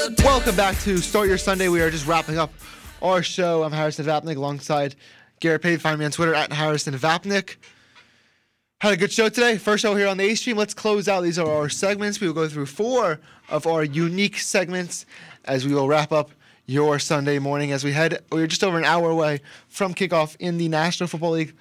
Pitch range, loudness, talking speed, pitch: 150-195 Hz, -22 LUFS, 215 wpm, 165 Hz